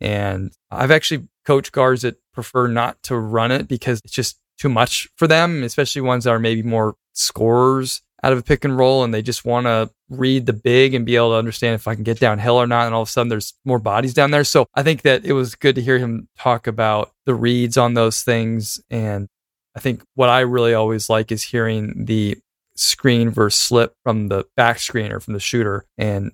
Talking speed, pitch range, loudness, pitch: 230 wpm, 110-130 Hz, -18 LUFS, 120 Hz